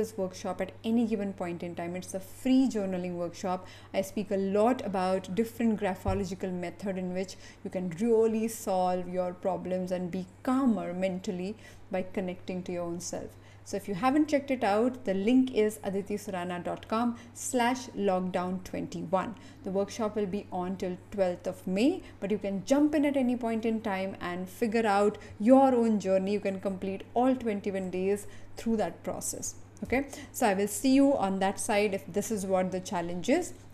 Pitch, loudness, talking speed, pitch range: 200 Hz, -30 LUFS, 180 wpm, 185-225 Hz